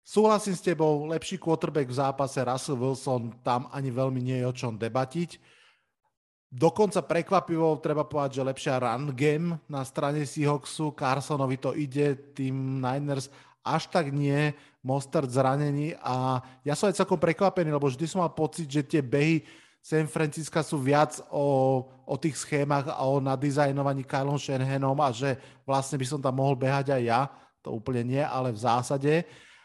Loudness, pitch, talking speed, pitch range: -28 LUFS, 140 Hz, 165 wpm, 135-155 Hz